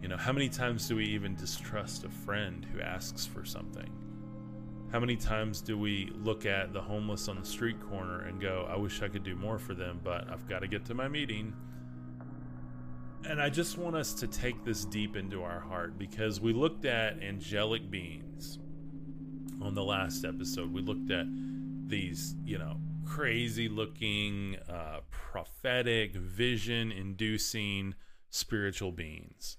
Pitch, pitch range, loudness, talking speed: 105 Hz, 95-120 Hz, -36 LUFS, 165 wpm